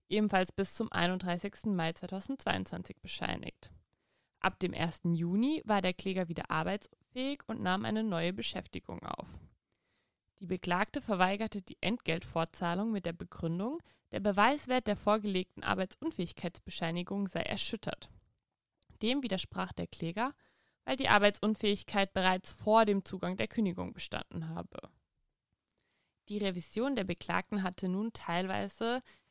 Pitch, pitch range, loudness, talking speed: 195 Hz, 175-215 Hz, -34 LUFS, 120 wpm